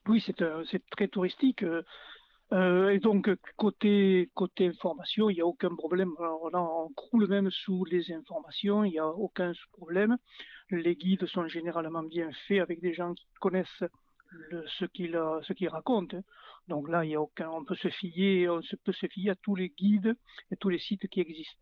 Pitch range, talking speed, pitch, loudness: 170-200 Hz, 195 wpm, 185 Hz, -31 LUFS